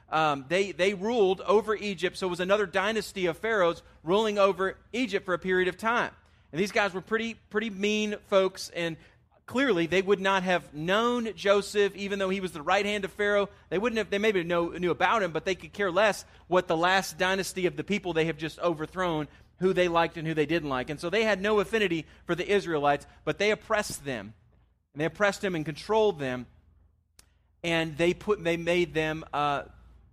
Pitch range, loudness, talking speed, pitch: 160-205 Hz, -28 LUFS, 210 wpm, 185 Hz